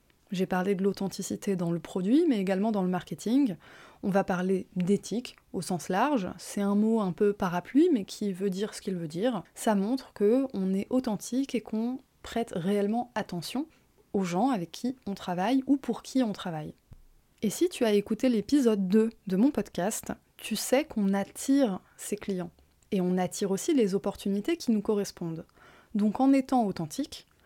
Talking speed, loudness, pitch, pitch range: 180 wpm, -29 LUFS, 205 Hz, 190-245 Hz